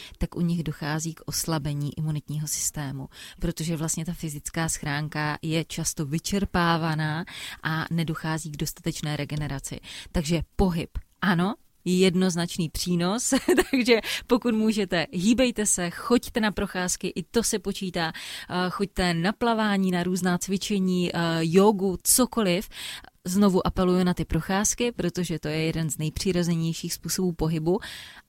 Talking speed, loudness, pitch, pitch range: 125 wpm, -26 LUFS, 175 Hz, 160-195 Hz